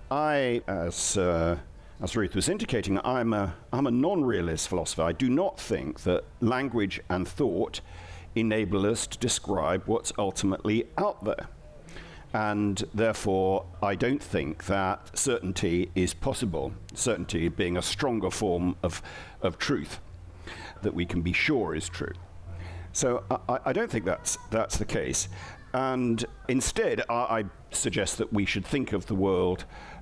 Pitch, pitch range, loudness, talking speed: 95 Hz, 90-110 Hz, -29 LUFS, 150 wpm